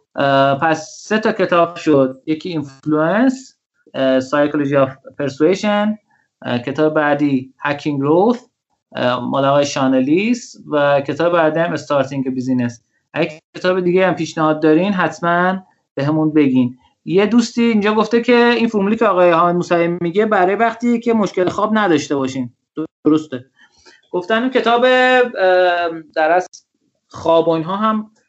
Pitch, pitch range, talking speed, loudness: 165 Hz, 145-210 Hz, 125 wpm, -16 LUFS